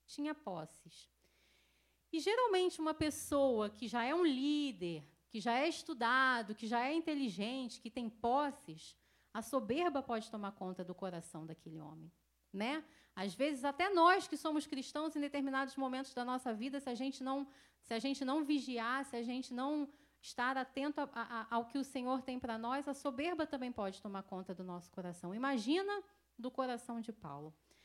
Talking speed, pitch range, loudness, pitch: 180 wpm, 220-290 Hz, -39 LUFS, 255 Hz